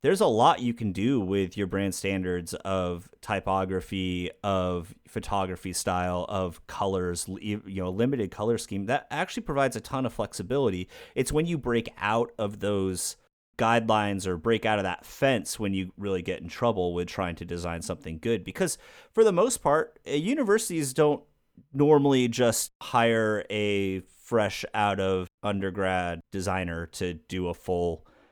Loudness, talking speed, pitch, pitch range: -28 LUFS, 160 wpm, 95 Hz, 90-115 Hz